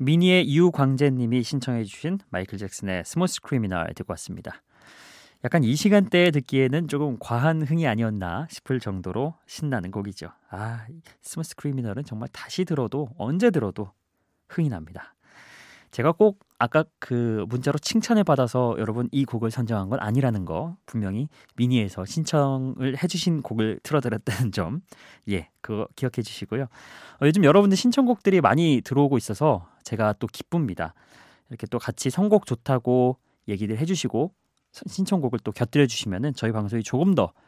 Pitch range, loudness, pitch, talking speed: 110-160 Hz, -24 LUFS, 130 Hz, 345 characters per minute